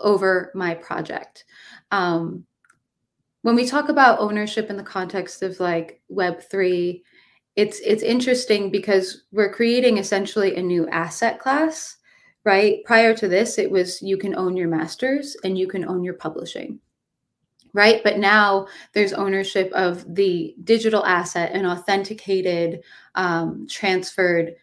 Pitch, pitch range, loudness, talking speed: 195 Hz, 180-215 Hz, -21 LUFS, 140 wpm